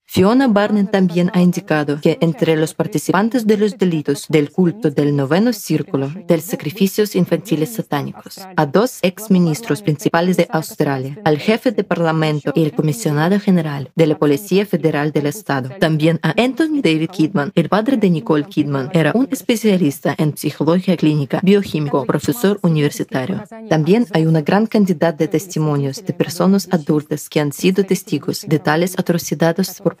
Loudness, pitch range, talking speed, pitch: -17 LUFS, 155-190 Hz, 160 wpm, 165 Hz